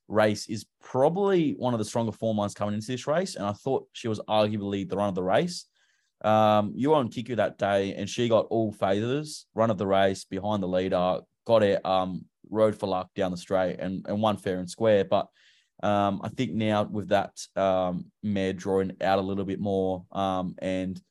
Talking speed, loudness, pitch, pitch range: 215 wpm, -27 LUFS, 100 Hz, 95-110 Hz